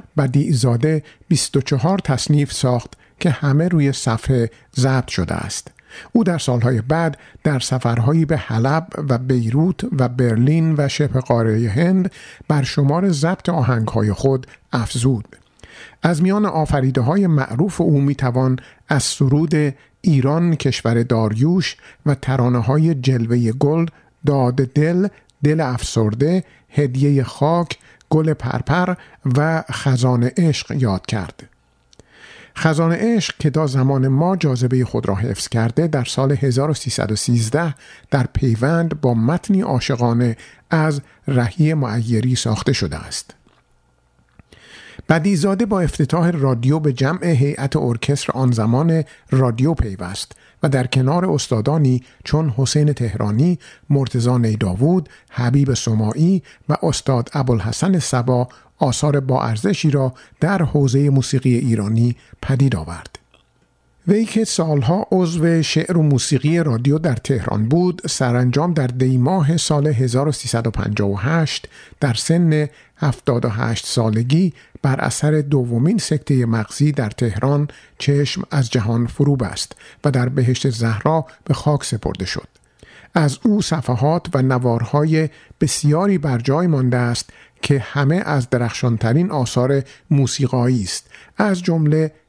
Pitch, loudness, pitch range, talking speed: 140 Hz, -18 LUFS, 125-155 Hz, 120 wpm